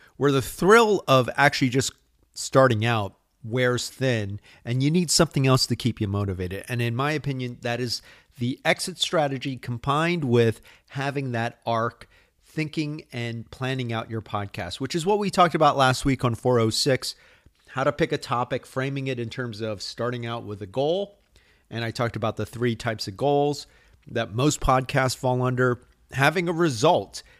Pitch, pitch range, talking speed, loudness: 130 Hz, 115-145 Hz, 175 wpm, -24 LUFS